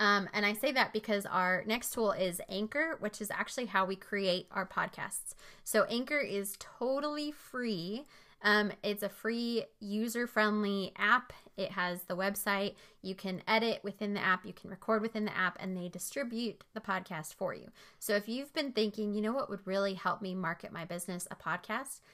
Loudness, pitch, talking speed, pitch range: -34 LUFS, 205 Hz, 190 wpm, 190-225 Hz